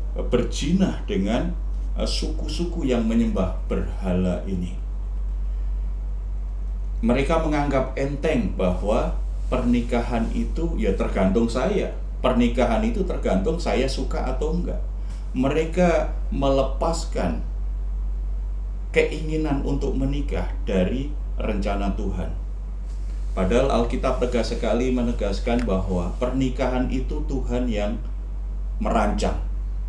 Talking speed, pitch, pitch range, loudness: 85 wpm, 120 Hz, 95-135 Hz, -25 LUFS